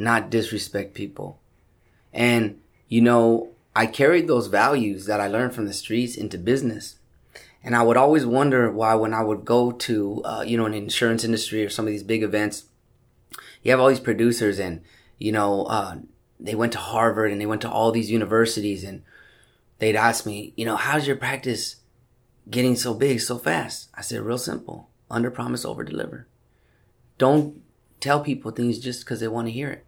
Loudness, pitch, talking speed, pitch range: -23 LUFS, 115 Hz, 190 wpm, 105-120 Hz